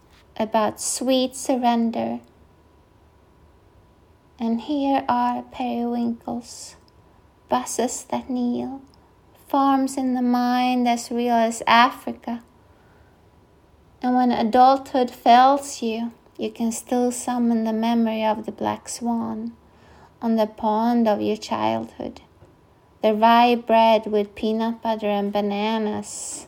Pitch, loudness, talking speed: 225 Hz, -22 LUFS, 105 wpm